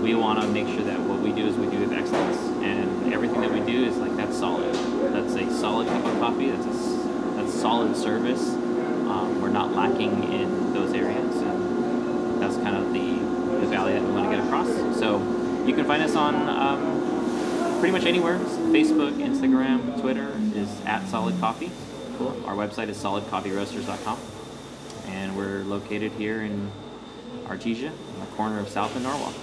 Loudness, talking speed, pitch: -25 LUFS, 180 wpm, 110 Hz